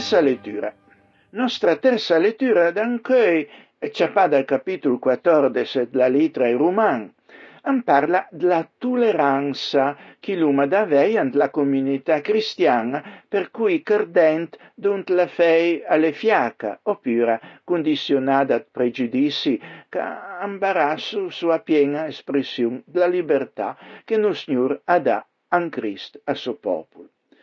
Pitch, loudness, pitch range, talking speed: 170 Hz, -21 LUFS, 140-210 Hz, 115 wpm